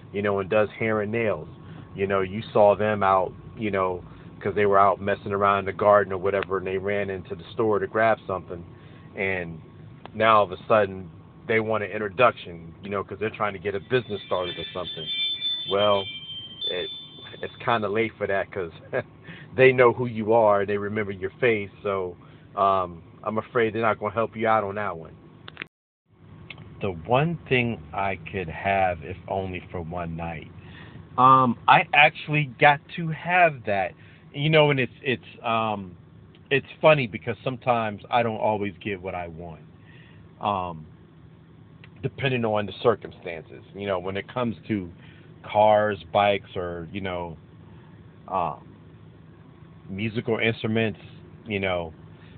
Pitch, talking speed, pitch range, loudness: 105 Hz, 165 wpm, 95-115 Hz, -24 LUFS